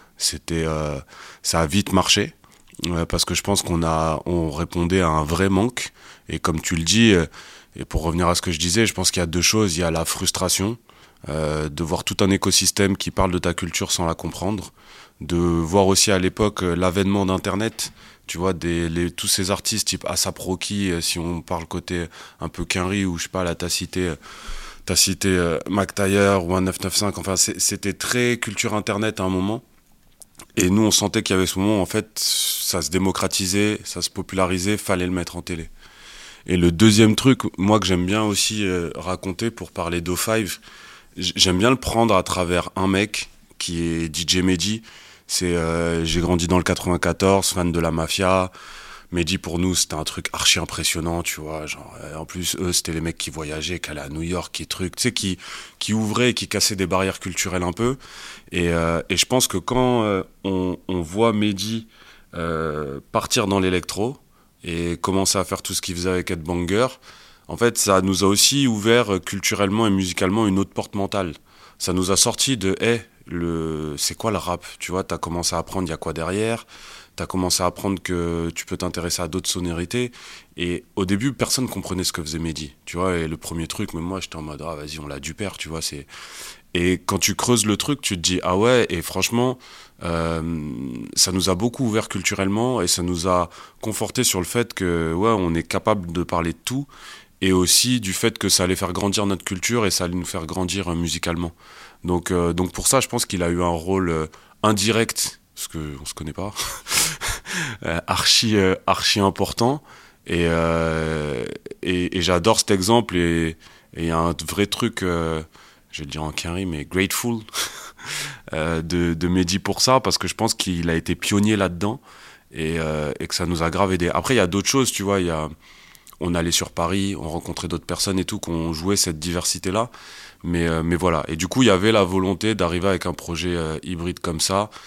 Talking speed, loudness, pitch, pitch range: 215 wpm, -21 LUFS, 90 Hz, 85-100 Hz